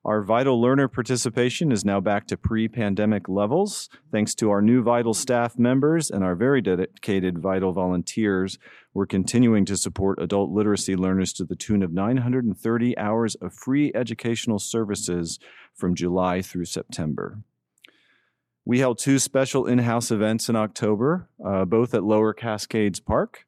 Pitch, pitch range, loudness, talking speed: 110 Hz, 95-120 Hz, -23 LUFS, 155 wpm